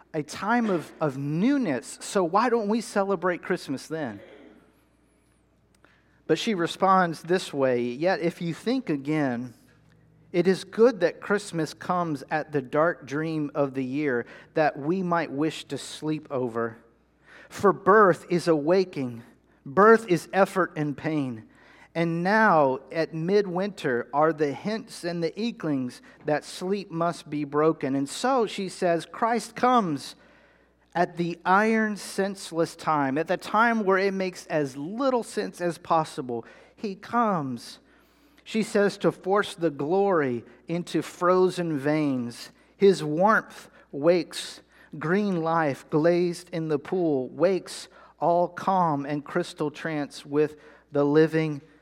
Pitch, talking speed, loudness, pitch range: 165 Hz, 135 wpm, -26 LUFS, 150-190 Hz